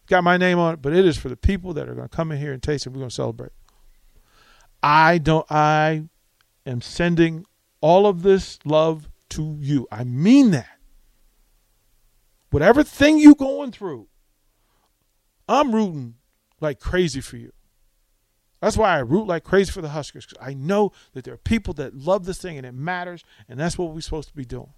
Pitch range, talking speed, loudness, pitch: 120-180 Hz, 195 wpm, -20 LUFS, 150 Hz